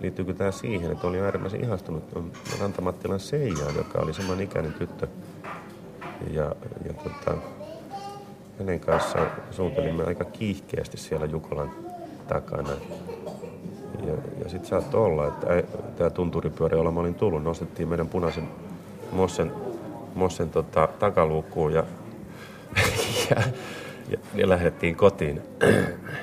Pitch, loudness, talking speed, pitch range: 90 Hz, -27 LUFS, 110 wpm, 80-95 Hz